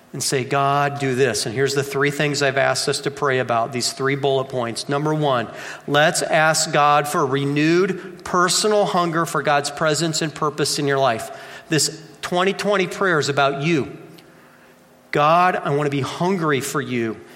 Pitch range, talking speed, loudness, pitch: 140-165 Hz, 175 wpm, -19 LUFS, 145 Hz